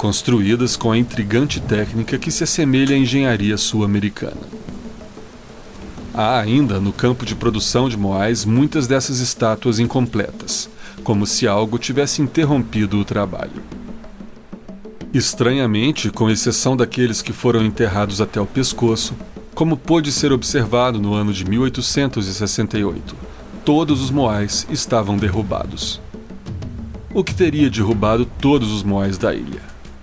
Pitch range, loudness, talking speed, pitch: 105-135 Hz, -18 LUFS, 125 wpm, 115 Hz